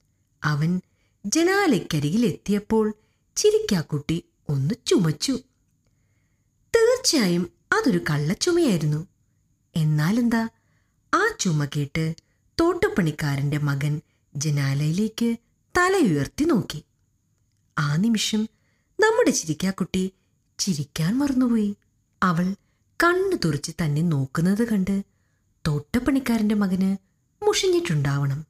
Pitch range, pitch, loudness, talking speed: 150-235 Hz, 185 Hz, -23 LUFS, 65 wpm